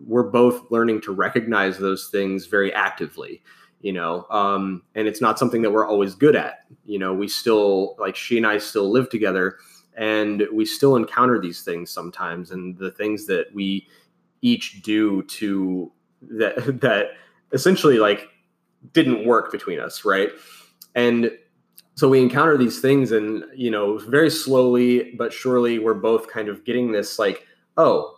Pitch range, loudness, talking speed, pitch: 100-125 Hz, -20 LUFS, 165 wpm, 110 Hz